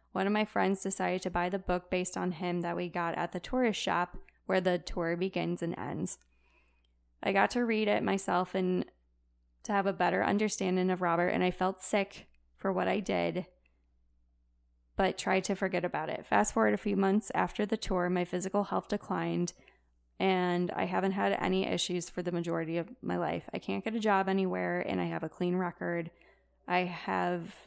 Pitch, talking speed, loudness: 180 Hz, 195 wpm, -32 LUFS